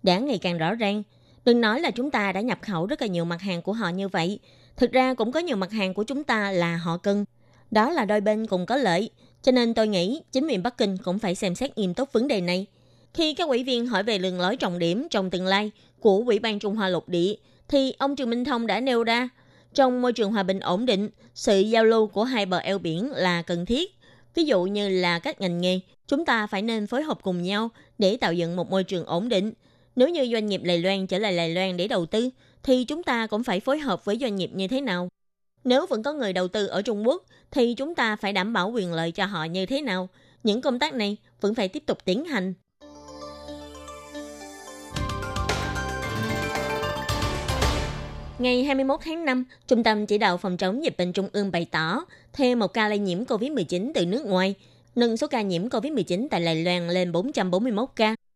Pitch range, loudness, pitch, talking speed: 180-245 Hz, -25 LUFS, 205 Hz, 230 wpm